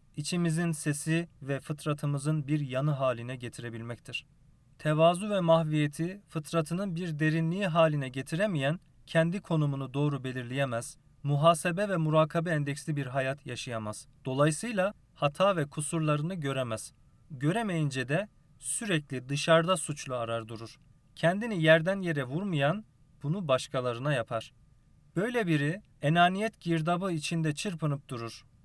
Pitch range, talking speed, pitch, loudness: 135-165 Hz, 110 wpm, 150 Hz, -30 LUFS